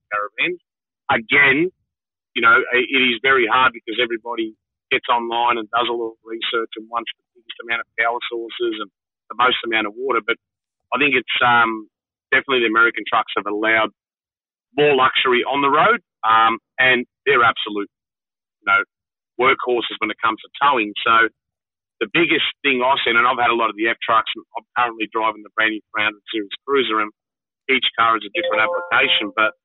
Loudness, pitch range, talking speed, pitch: -18 LUFS, 110-155 Hz, 185 wpm, 115 Hz